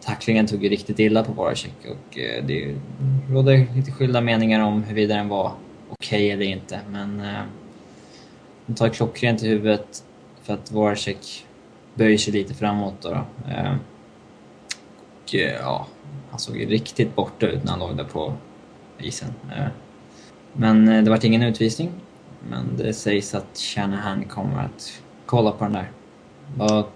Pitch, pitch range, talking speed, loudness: 105 Hz, 100-115 Hz, 160 wpm, -22 LUFS